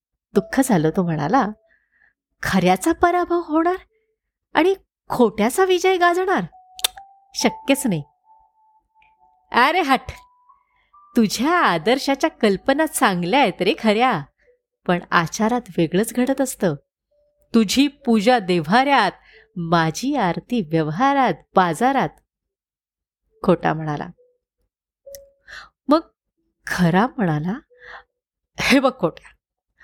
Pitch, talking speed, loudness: 260 Hz, 85 wpm, -19 LUFS